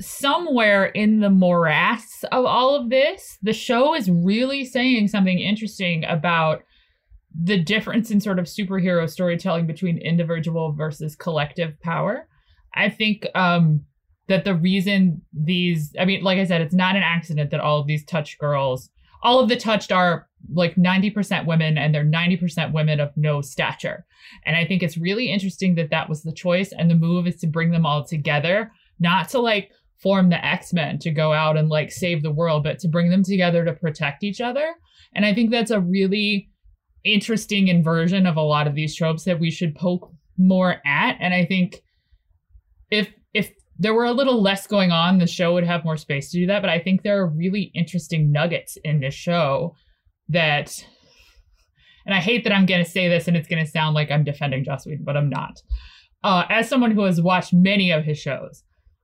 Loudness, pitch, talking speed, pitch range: -20 LUFS, 175 Hz, 195 wpm, 155-195 Hz